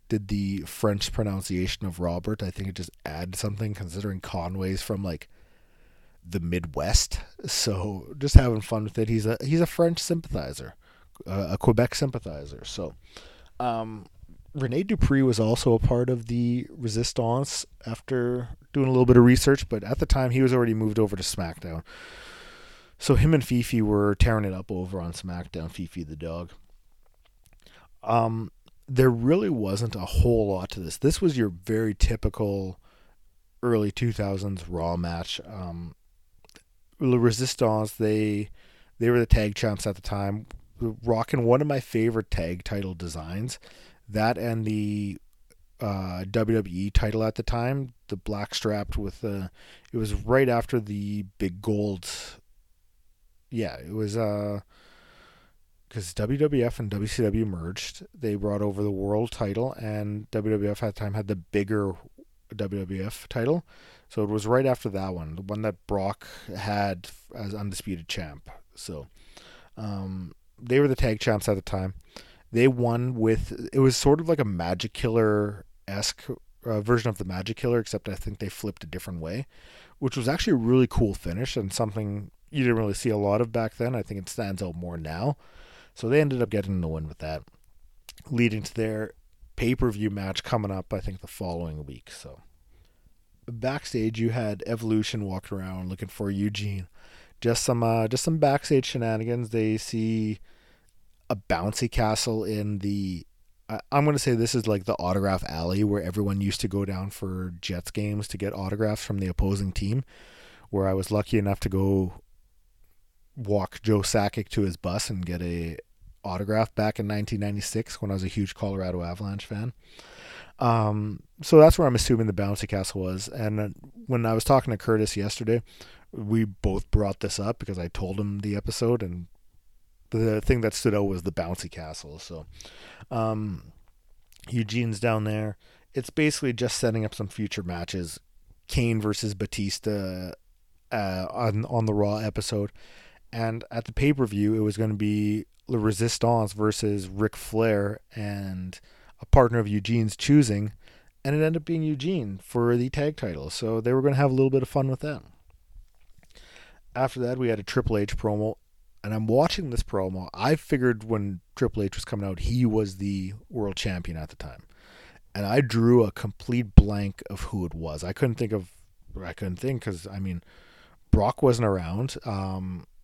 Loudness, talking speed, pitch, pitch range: -27 LUFS, 175 wpm, 105 Hz, 95-115 Hz